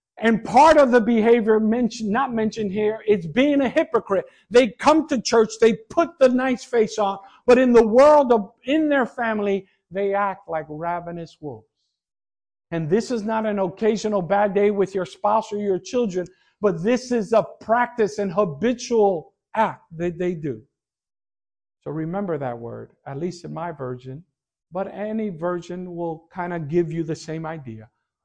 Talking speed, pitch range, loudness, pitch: 170 wpm, 175-230 Hz, -21 LUFS, 205 Hz